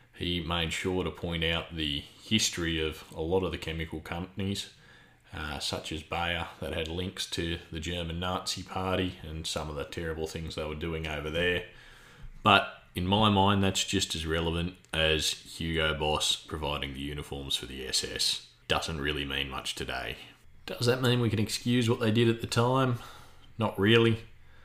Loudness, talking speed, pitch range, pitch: -30 LUFS, 180 wpm, 80-95 Hz, 85 Hz